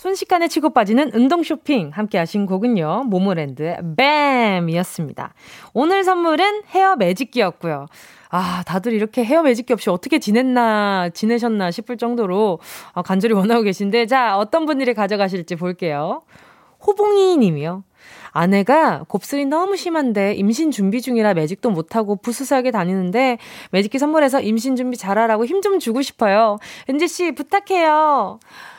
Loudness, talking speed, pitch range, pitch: -18 LUFS, 340 characters per minute, 195-285 Hz, 235 Hz